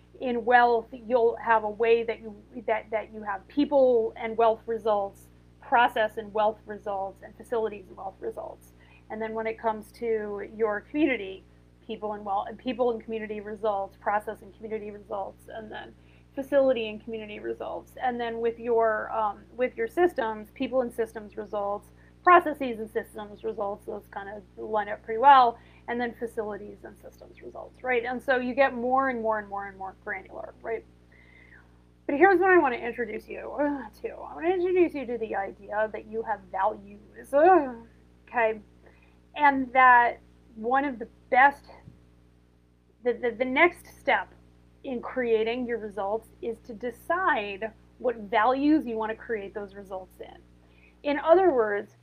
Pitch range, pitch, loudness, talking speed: 205-245 Hz, 220 Hz, -26 LUFS, 170 wpm